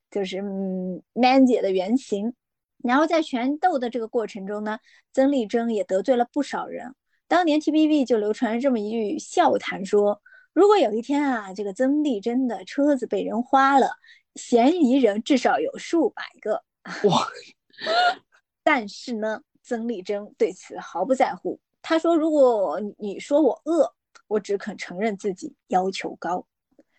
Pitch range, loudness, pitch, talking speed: 210-290 Hz, -23 LUFS, 245 Hz, 235 characters per minute